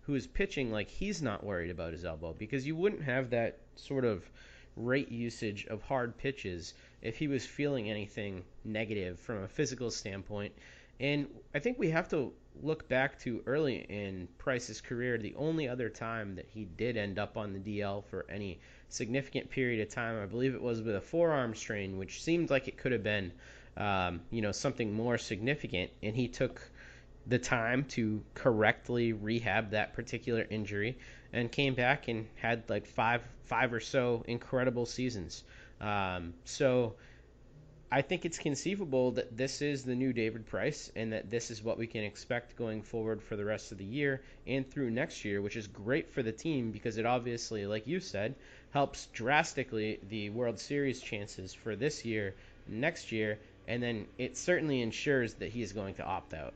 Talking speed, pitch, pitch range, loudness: 185 wpm, 115 Hz, 105-130 Hz, -35 LUFS